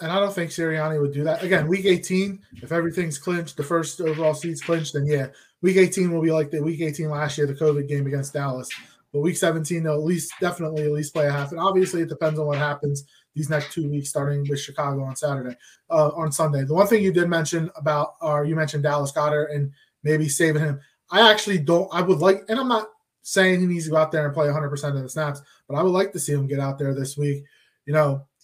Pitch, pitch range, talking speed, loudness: 155 Hz, 145-170 Hz, 250 wpm, -23 LUFS